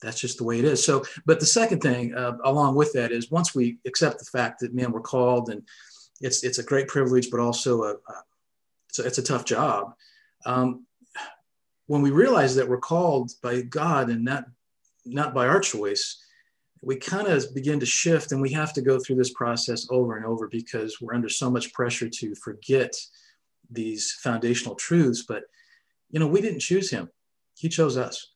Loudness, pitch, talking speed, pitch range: -24 LUFS, 130 Hz, 200 wpm, 120-160 Hz